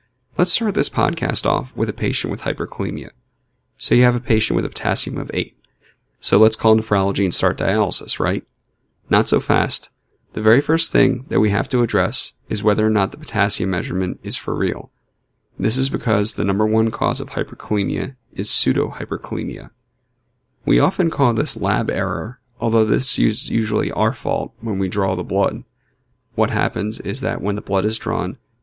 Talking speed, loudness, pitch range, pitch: 180 wpm, -19 LUFS, 100-125 Hz, 110 Hz